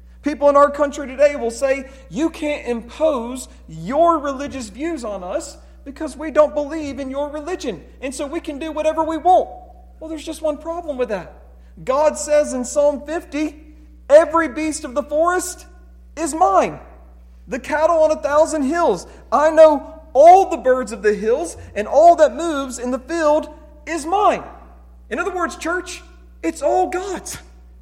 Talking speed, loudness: 170 wpm, -18 LUFS